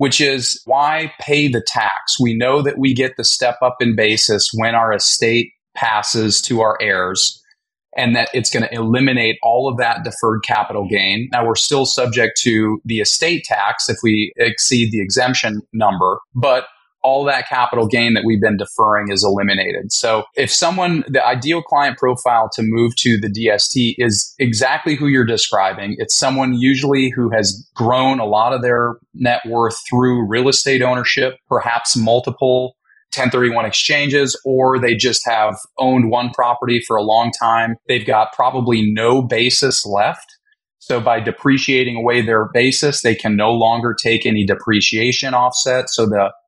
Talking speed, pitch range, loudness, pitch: 170 wpm, 110-130 Hz, -15 LUFS, 120 Hz